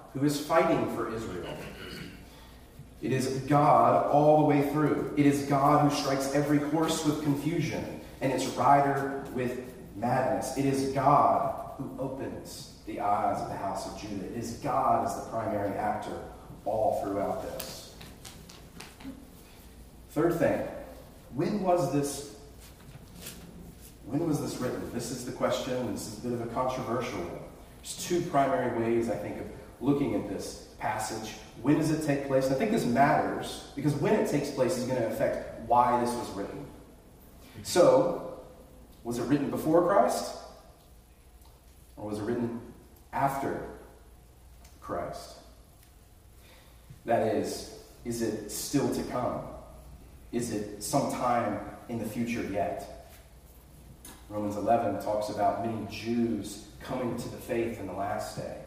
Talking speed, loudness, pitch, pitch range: 145 wpm, -29 LUFS, 120 Hz, 105-140 Hz